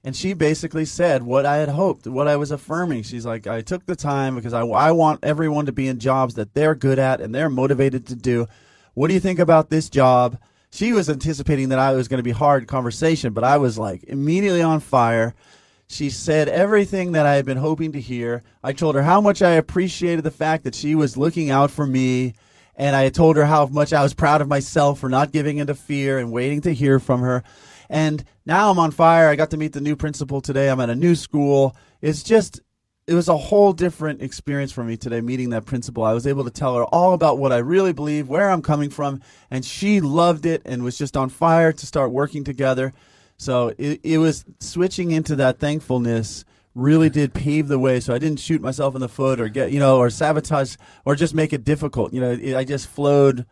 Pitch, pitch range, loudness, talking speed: 145 Hz, 130-155 Hz, -19 LUFS, 235 wpm